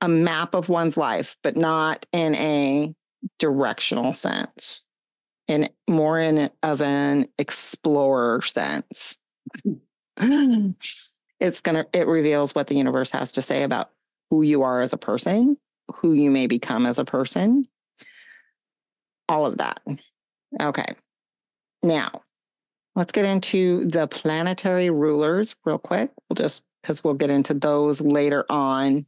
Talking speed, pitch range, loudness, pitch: 135 wpm, 145-180 Hz, -22 LUFS, 155 Hz